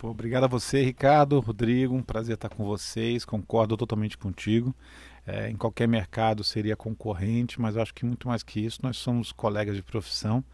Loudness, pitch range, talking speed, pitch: -27 LUFS, 110-120 Hz, 180 wpm, 115 Hz